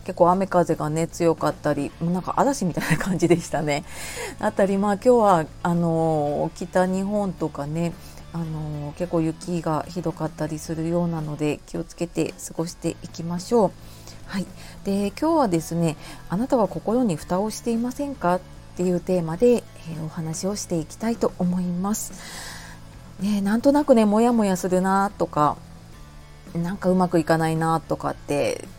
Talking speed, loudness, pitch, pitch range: 330 characters per minute, -23 LUFS, 175 Hz, 160-195 Hz